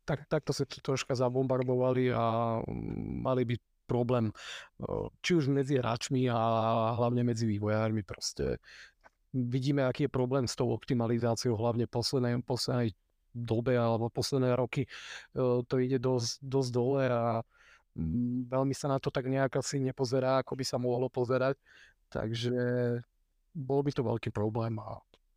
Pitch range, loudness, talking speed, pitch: 115-135 Hz, -32 LUFS, 140 wpm, 125 Hz